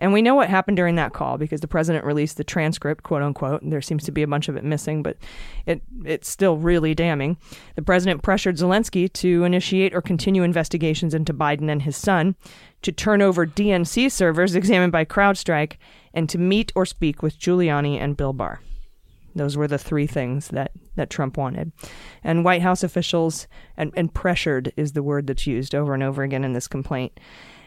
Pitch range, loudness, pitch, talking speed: 145-180 Hz, -22 LUFS, 165 Hz, 200 wpm